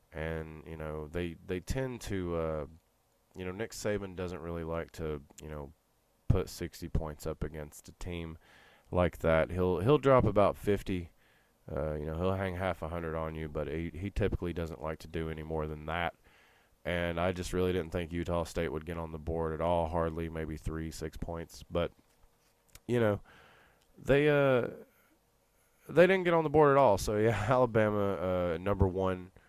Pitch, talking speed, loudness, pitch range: 85 Hz, 190 wpm, -32 LUFS, 80-95 Hz